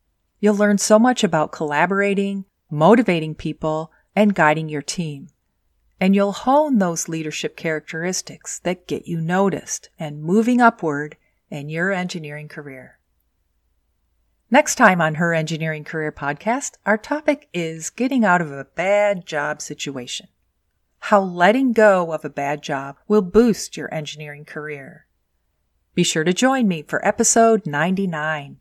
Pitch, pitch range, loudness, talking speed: 160 Hz, 150-200 Hz, -19 LUFS, 140 wpm